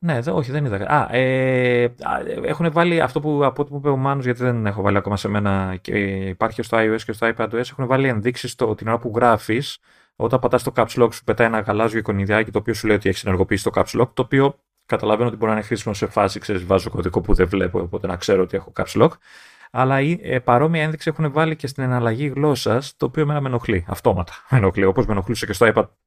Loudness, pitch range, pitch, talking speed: -20 LUFS, 105-135 Hz, 120 Hz, 245 wpm